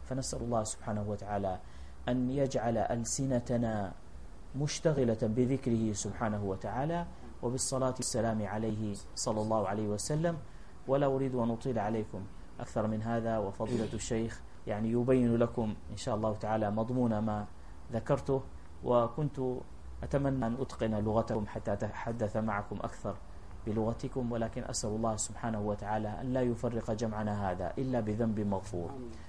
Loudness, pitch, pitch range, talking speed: -34 LUFS, 110 Hz, 105-125 Hz, 125 wpm